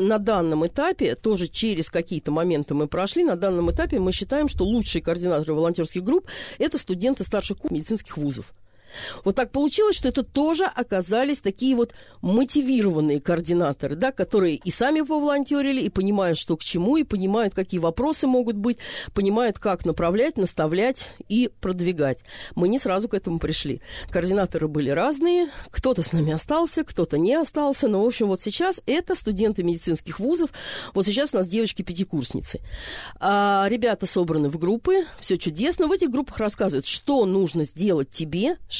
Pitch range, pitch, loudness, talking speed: 170-260 Hz, 200 Hz, -23 LUFS, 160 wpm